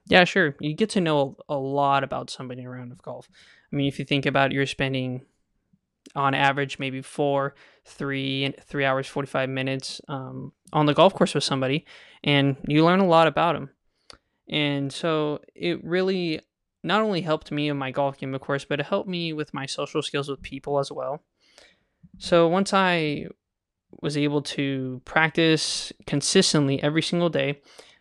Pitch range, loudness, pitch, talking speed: 135-160 Hz, -24 LUFS, 145 Hz, 175 wpm